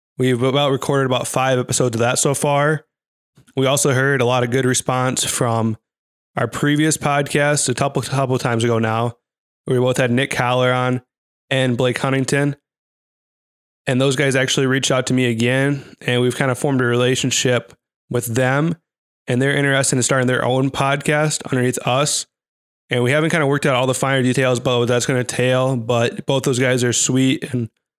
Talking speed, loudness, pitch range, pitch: 190 wpm, -18 LUFS, 125-140 Hz, 130 Hz